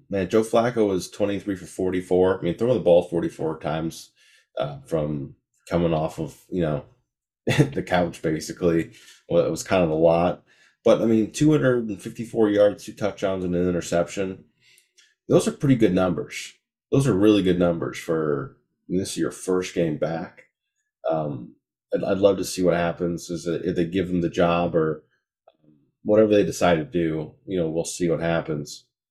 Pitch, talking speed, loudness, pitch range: 90 Hz, 185 wpm, -23 LUFS, 85-105 Hz